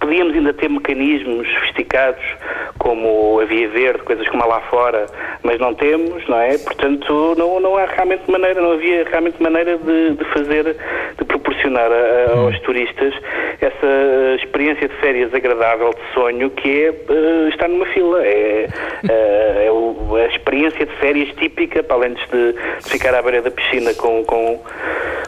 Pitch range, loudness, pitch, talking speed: 120-185 Hz, -16 LUFS, 150 Hz, 160 wpm